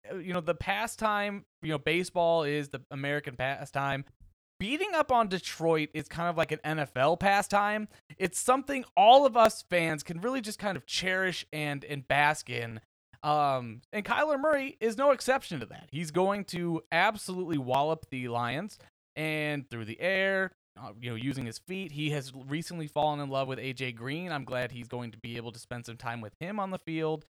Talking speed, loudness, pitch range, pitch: 195 wpm, -30 LUFS, 135-190 Hz, 155 Hz